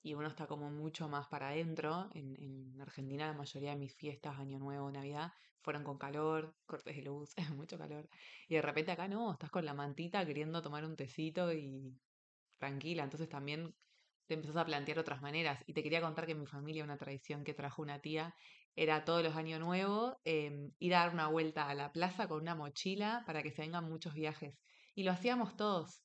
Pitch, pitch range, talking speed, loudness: 155 Hz, 145-165 Hz, 210 wpm, -41 LUFS